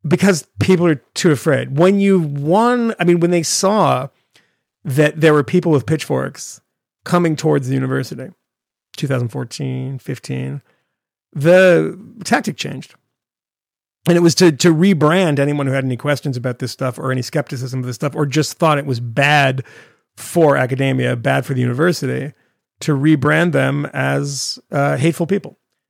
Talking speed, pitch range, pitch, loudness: 155 wpm, 130-170 Hz, 145 Hz, -16 LUFS